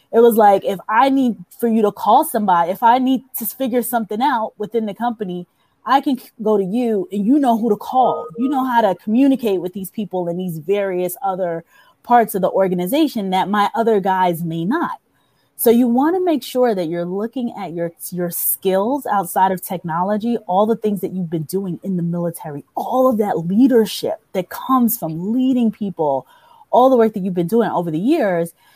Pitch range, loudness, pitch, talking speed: 185-245 Hz, -18 LUFS, 210 Hz, 205 wpm